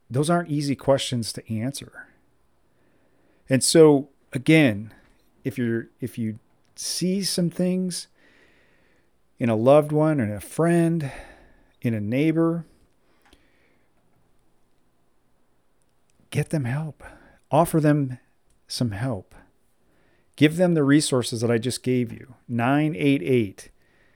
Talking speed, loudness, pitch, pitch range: 110 wpm, -23 LUFS, 135 Hz, 120-155 Hz